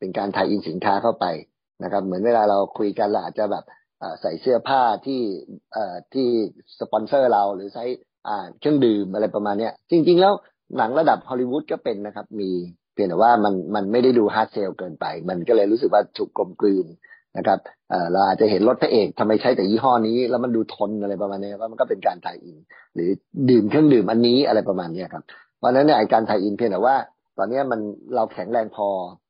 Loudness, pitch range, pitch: -21 LUFS, 105-130 Hz, 115 Hz